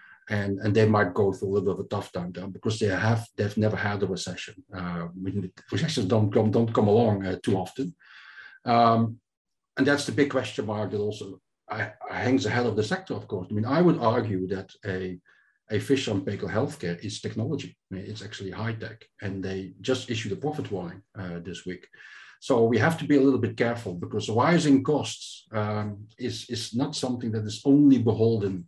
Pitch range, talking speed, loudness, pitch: 95-120 Hz, 205 wpm, -26 LUFS, 105 Hz